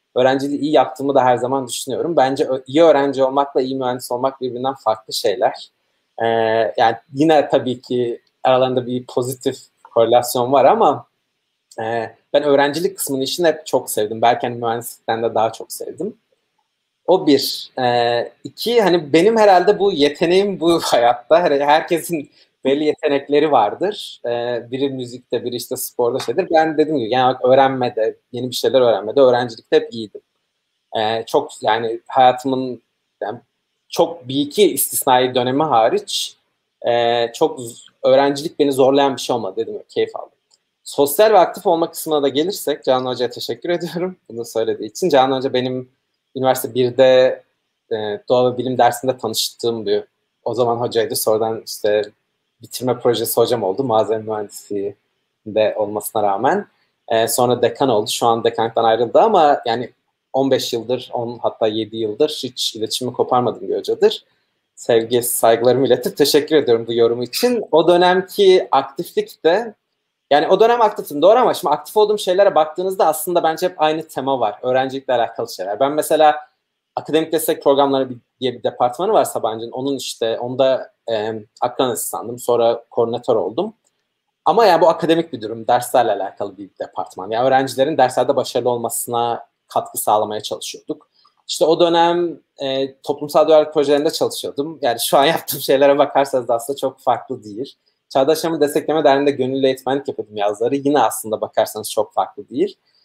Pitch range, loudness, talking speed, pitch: 120-155 Hz, -17 LUFS, 150 wpm, 130 Hz